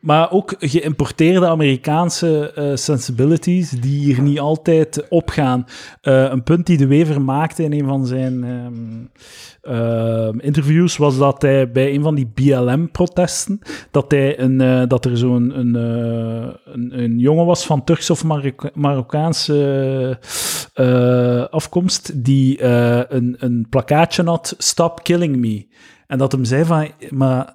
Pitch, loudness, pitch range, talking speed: 140 Hz, -16 LUFS, 130-160 Hz, 150 wpm